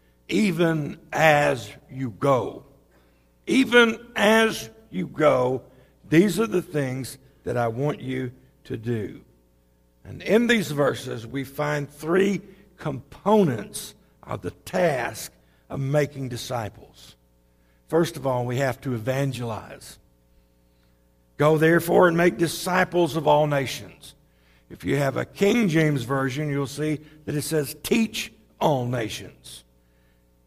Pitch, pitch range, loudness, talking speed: 140 Hz, 110-160 Hz, -23 LUFS, 120 wpm